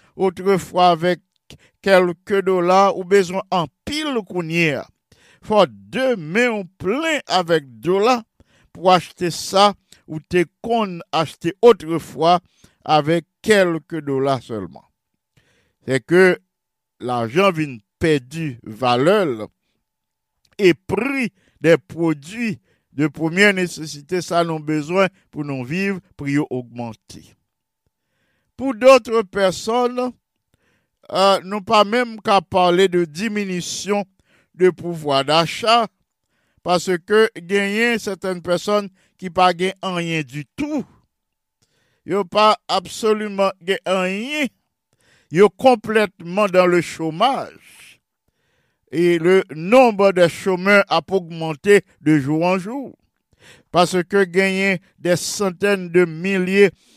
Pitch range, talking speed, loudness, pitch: 160-200 Hz, 105 wpm, -18 LUFS, 180 Hz